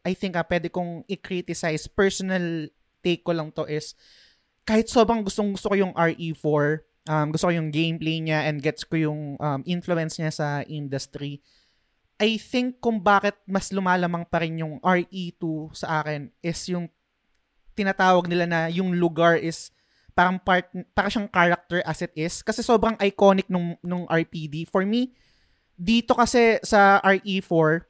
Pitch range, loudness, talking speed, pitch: 160-195 Hz, -24 LUFS, 160 wpm, 175 Hz